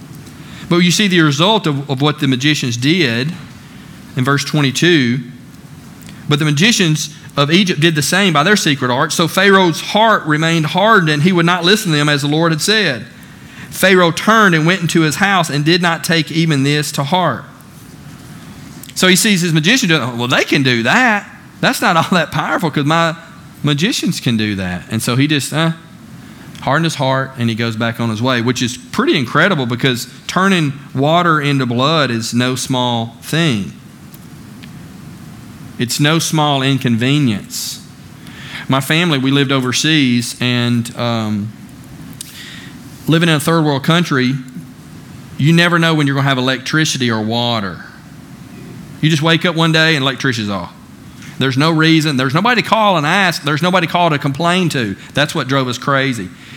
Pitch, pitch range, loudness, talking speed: 150 Hz, 130-170 Hz, -13 LUFS, 175 wpm